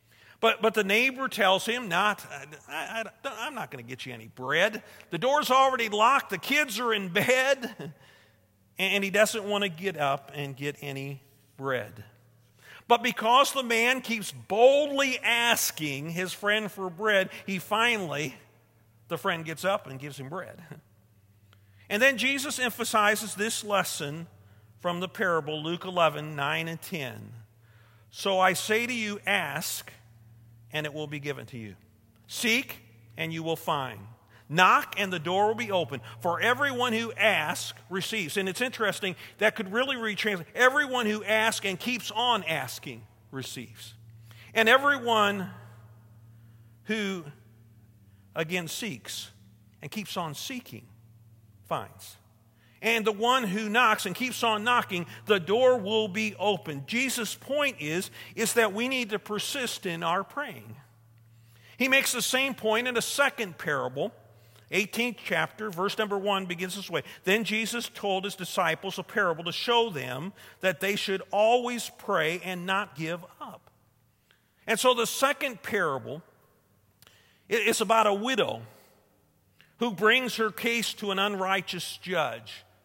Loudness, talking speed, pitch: -27 LUFS, 150 wpm, 190 Hz